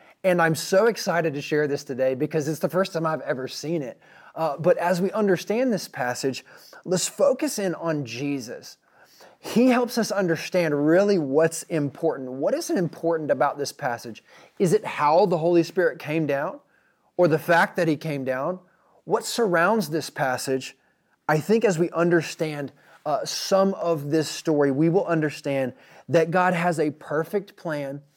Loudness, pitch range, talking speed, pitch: -24 LUFS, 145-185 Hz, 170 wpm, 165 Hz